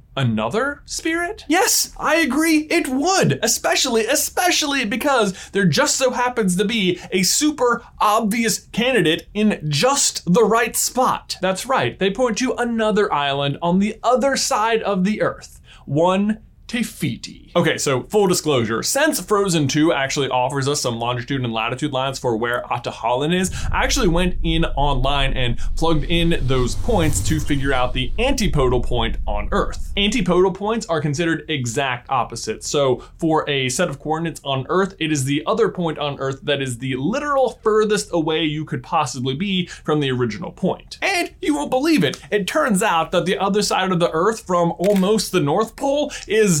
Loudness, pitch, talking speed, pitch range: -19 LUFS, 185 Hz, 170 wpm, 150-230 Hz